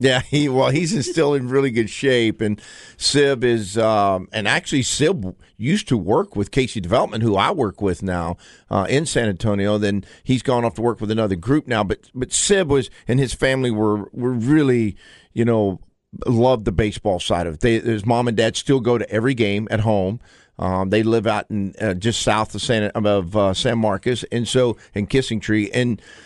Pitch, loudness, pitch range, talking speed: 115 Hz, -20 LUFS, 105-125 Hz, 210 wpm